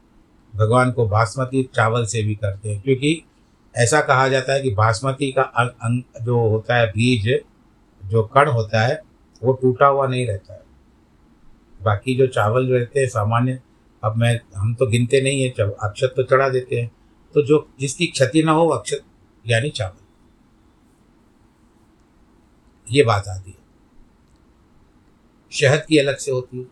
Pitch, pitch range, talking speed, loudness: 120 Hz, 105-130 Hz, 155 wpm, -19 LUFS